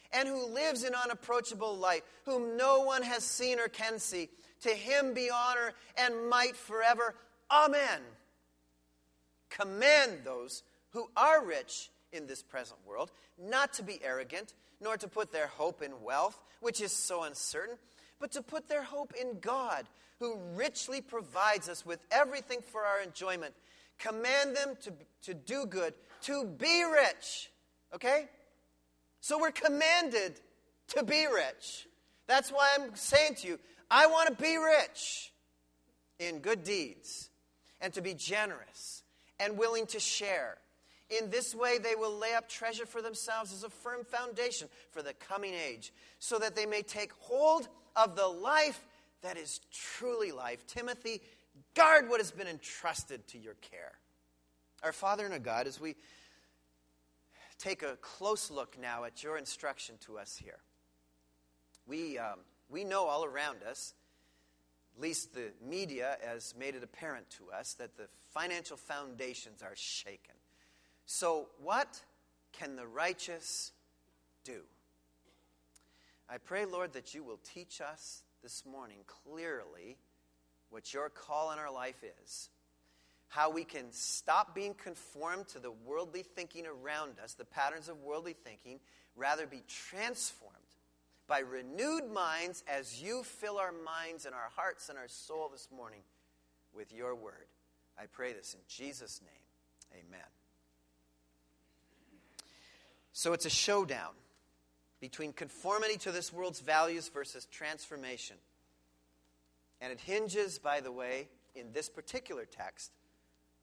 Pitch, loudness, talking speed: 170 Hz, -34 LUFS, 145 wpm